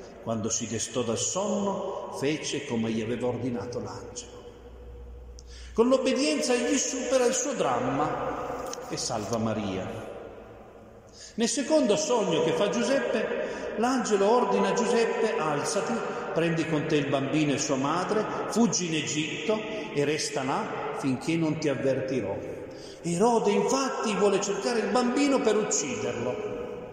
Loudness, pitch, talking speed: -27 LUFS, 165 Hz, 130 wpm